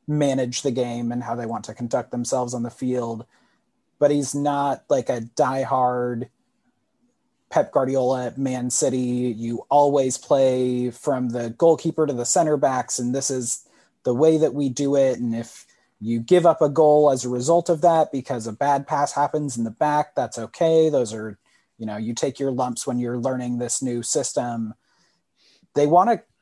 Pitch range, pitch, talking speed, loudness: 120-145 Hz, 130 Hz, 185 wpm, -22 LUFS